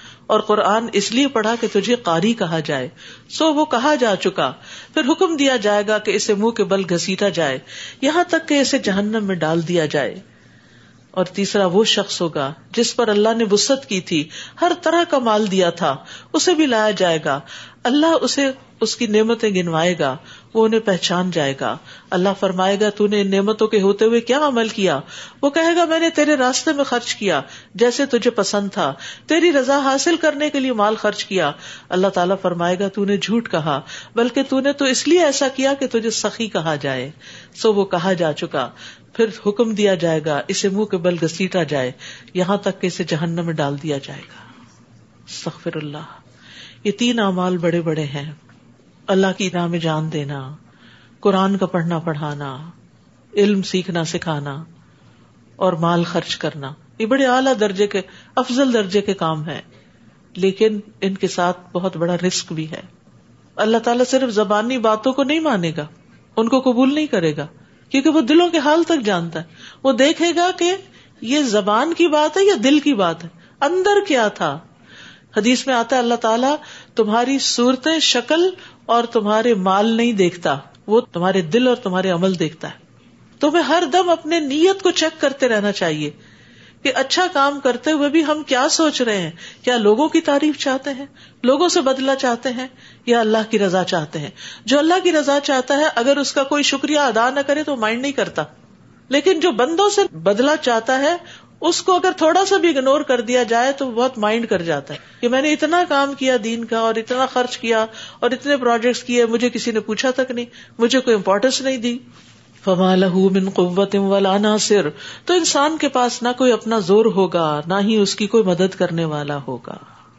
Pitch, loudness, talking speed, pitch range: 220 Hz, -18 LUFS, 195 wpm, 185-270 Hz